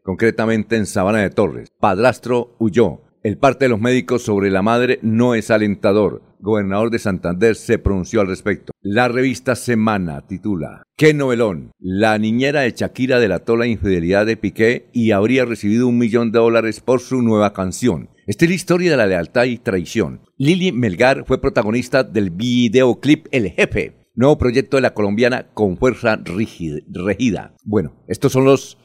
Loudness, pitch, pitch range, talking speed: -17 LUFS, 115 Hz, 105-125 Hz, 165 wpm